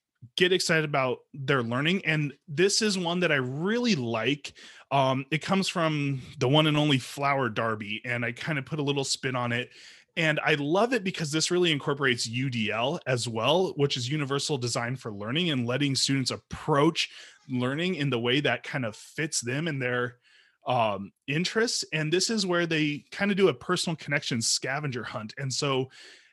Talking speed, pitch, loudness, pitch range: 185 wpm, 140 Hz, -27 LUFS, 125-165 Hz